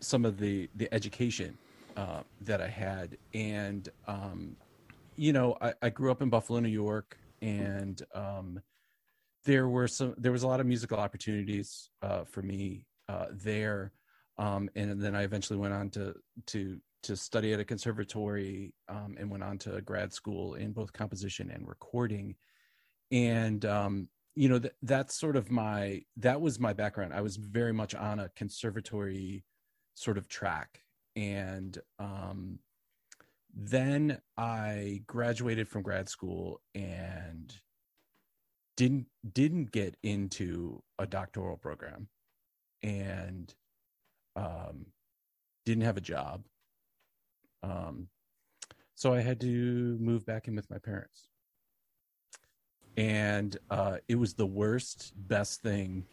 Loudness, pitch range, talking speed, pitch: -34 LUFS, 100-120 Hz, 135 wpm, 105 Hz